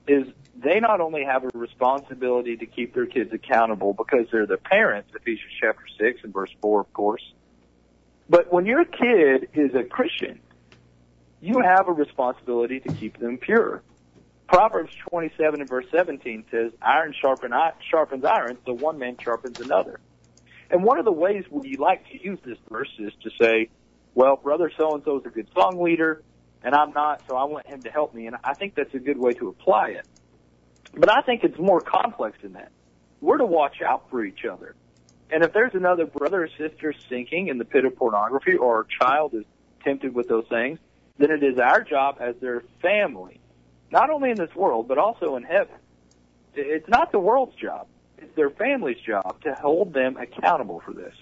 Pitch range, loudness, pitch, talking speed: 100-155 Hz, -23 LUFS, 130 Hz, 195 wpm